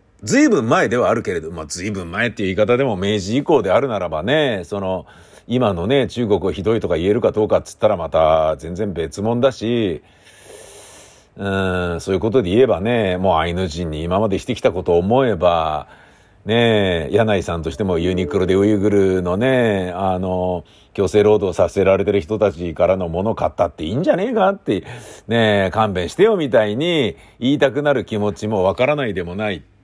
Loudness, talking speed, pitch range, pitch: -18 LUFS, 380 characters per minute, 90-110 Hz, 100 Hz